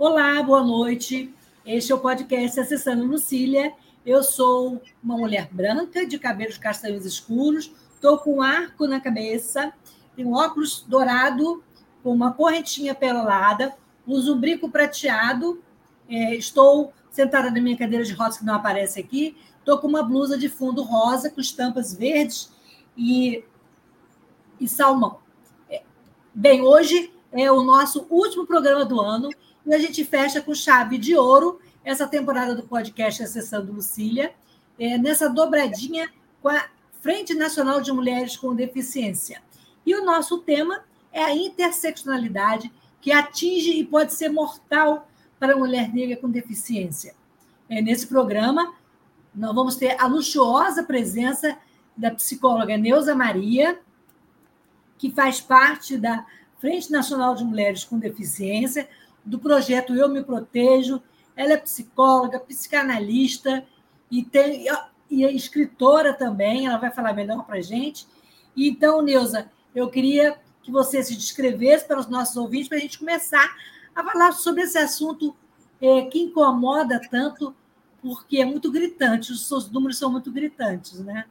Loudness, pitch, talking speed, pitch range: -21 LUFS, 265 Hz, 140 wpm, 245-295 Hz